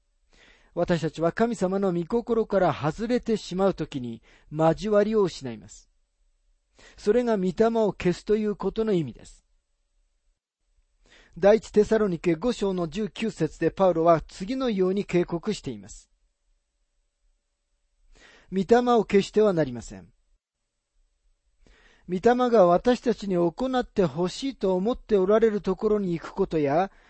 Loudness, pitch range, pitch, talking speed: -24 LUFS, 125-210 Hz, 185 Hz, 255 characters per minute